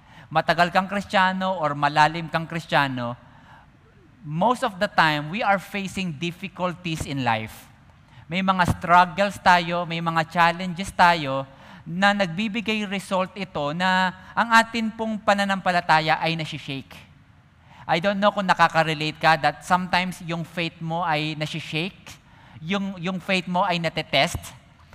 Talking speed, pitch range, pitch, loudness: 130 wpm, 155-190 Hz, 175 Hz, -22 LUFS